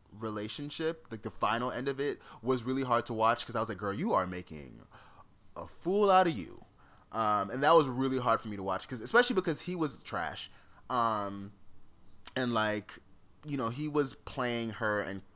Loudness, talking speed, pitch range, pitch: -32 LUFS, 200 wpm, 100-145 Hz, 115 Hz